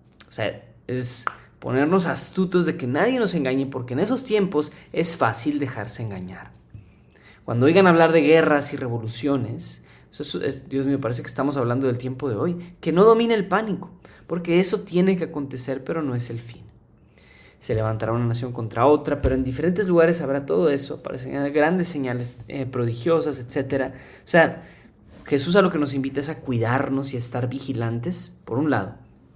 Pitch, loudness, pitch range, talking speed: 140 Hz, -22 LUFS, 120-165 Hz, 185 wpm